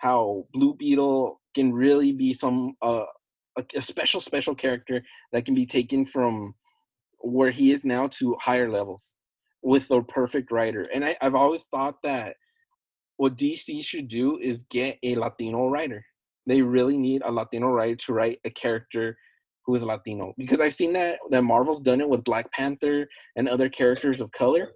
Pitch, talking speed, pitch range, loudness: 130 Hz, 175 wpm, 120-140 Hz, -25 LUFS